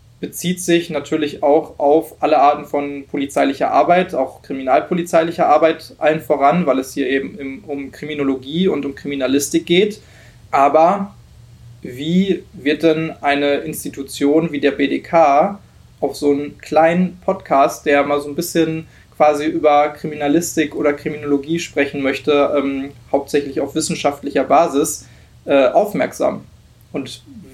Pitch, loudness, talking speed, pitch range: 145 Hz, -17 LUFS, 130 wpm, 140-160 Hz